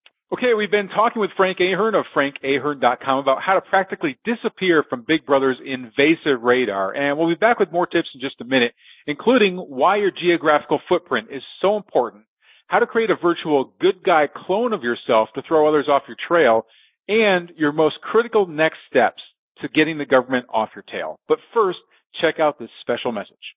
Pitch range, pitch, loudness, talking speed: 135-195 Hz, 155 Hz, -19 LUFS, 190 wpm